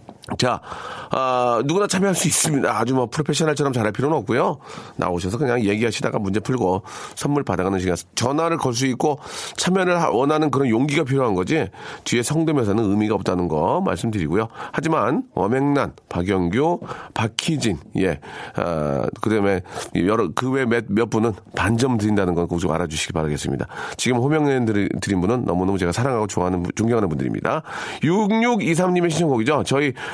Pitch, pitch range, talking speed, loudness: 120 Hz, 95-145 Hz, 385 characters per minute, -21 LUFS